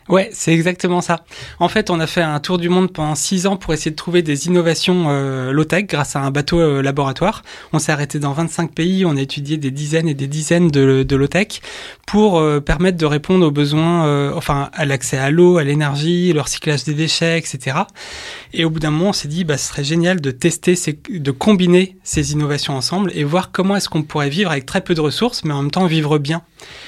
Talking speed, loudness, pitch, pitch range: 235 wpm, -17 LUFS, 160 Hz, 145-180 Hz